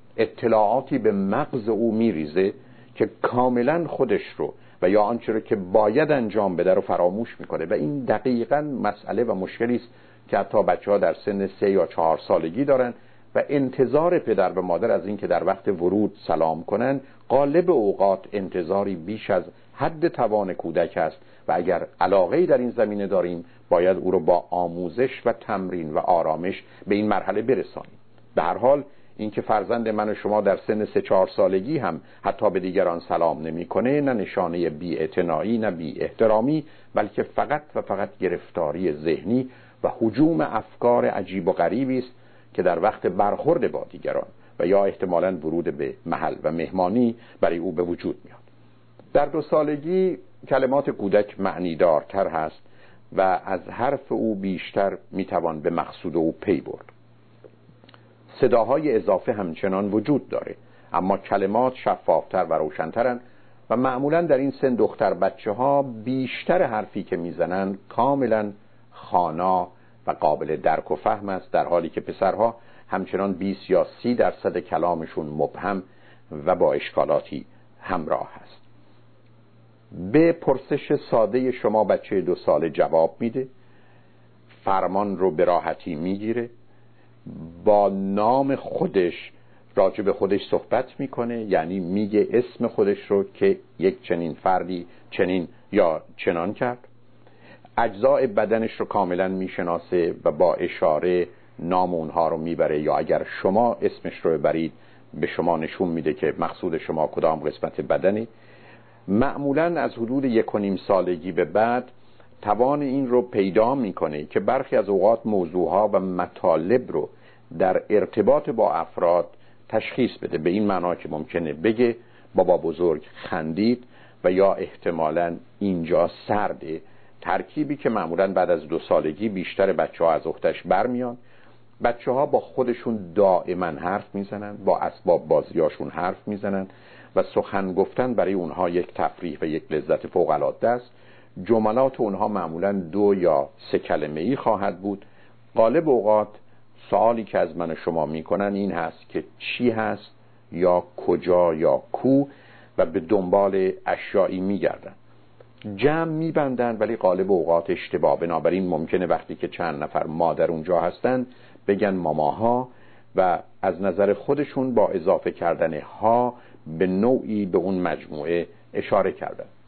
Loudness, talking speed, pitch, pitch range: -23 LUFS, 145 wpm, 110 Hz, 95-125 Hz